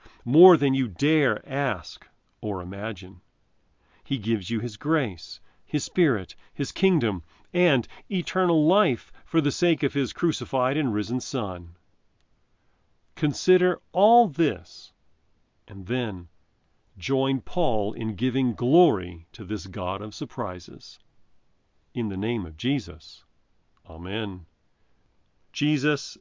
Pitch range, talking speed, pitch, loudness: 90-145 Hz, 115 wpm, 115 Hz, -25 LUFS